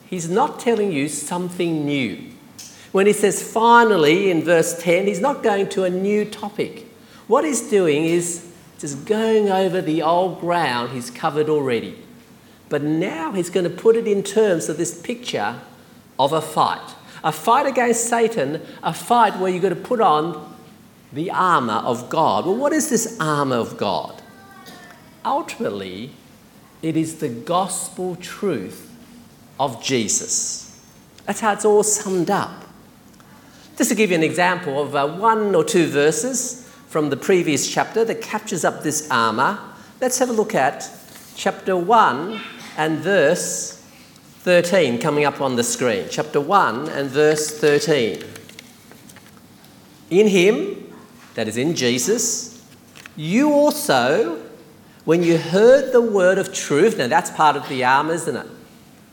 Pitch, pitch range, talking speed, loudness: 185 Hz, 160-225 Hz, 150 wpm, -19 LUFS